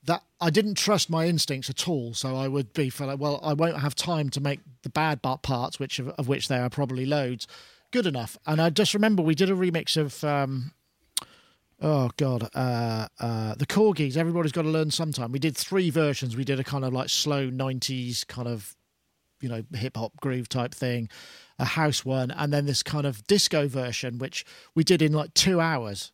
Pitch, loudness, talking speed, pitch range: 140 Hz, -26 LUFS, 210 wpm, 130-160 Hz